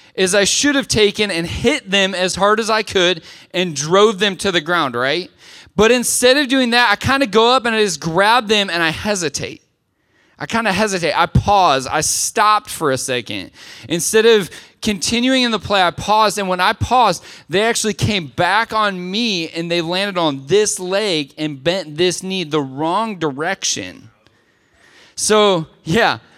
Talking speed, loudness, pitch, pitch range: 185 wpm, -16 LUFS, 195 Hz, 170-220 Hz